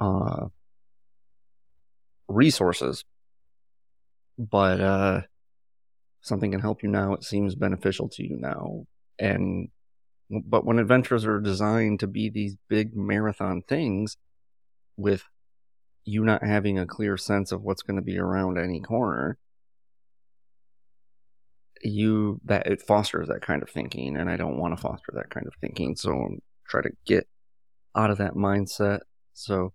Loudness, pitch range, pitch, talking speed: -26 LUFS, 85-105 Hz, 95 Hz, 140 wpm